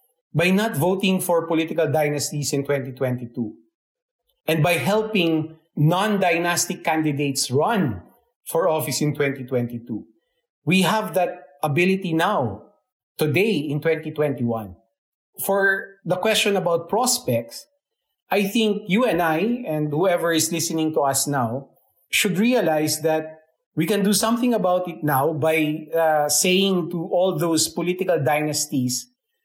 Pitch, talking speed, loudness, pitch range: 170 Hz, 125 wpm, -21 LUFS, 150-195 Hz